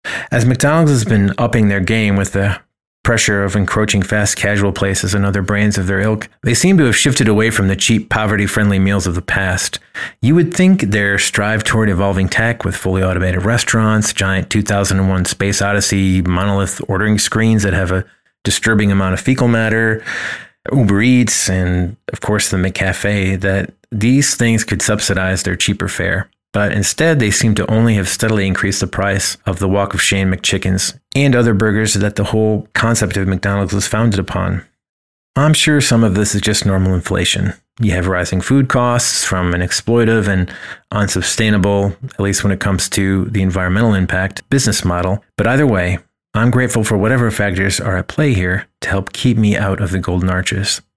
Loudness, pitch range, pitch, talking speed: -14 LUFS, 95-110 Hz, 100 Hz, 185 wpm